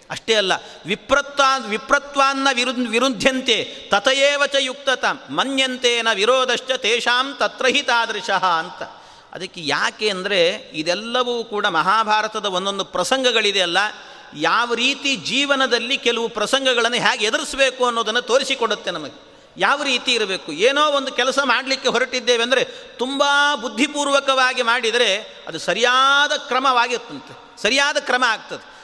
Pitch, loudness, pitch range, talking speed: 250 Hz, -18 LUFS, 230-270 Hz, 100 wpm